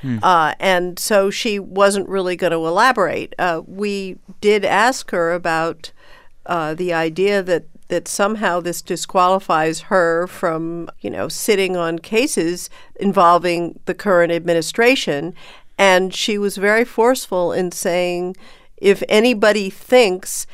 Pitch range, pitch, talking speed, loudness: 170-200 Hz, 185 Hz, 130 wpm, -17 LUFS